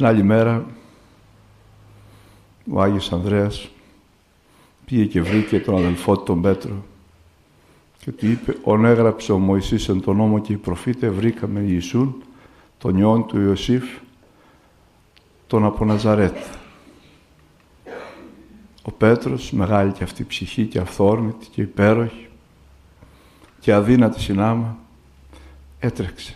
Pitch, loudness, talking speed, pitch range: 105 Hz, -19 LUFS, 115 wpm, 95-110 Hz